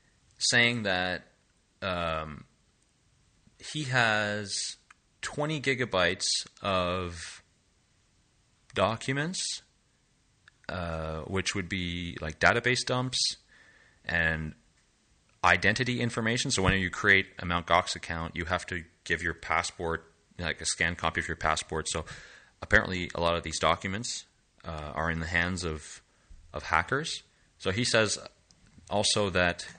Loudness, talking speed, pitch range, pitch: -29 LUFS, 120 wpm, 85-110 Hz, 90 Hz